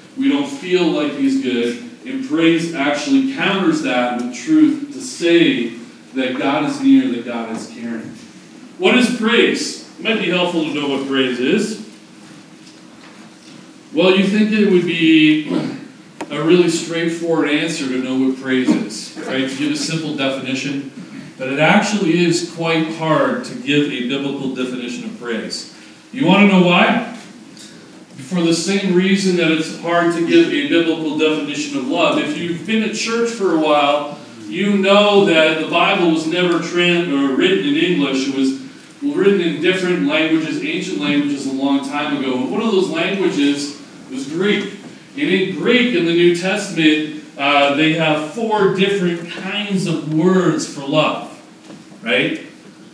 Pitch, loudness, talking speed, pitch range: 170 Hz, -16 LUFS, 165 wpm, 150-225 Hz